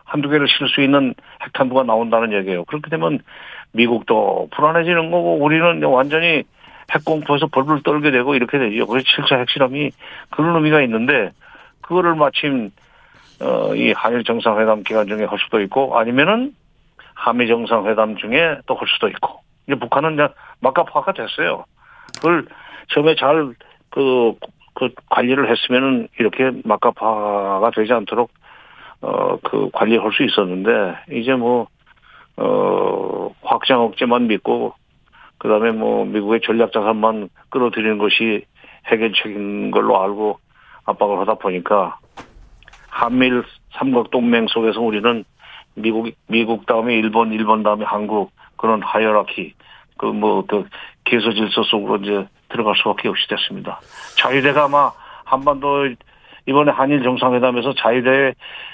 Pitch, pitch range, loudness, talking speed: 125 Hz, 110-145 Hz, -17 LUFS, 305 characters per minute